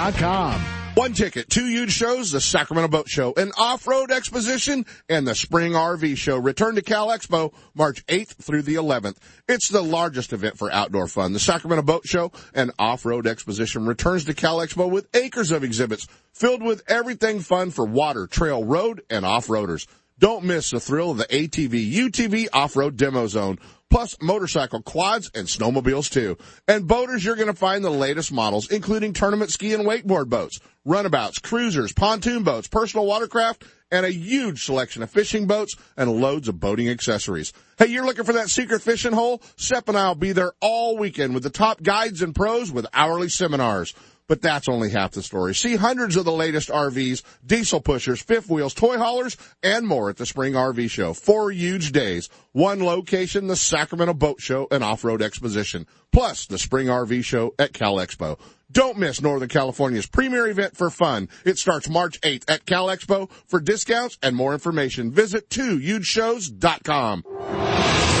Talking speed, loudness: 175 wpm, -22 LUFS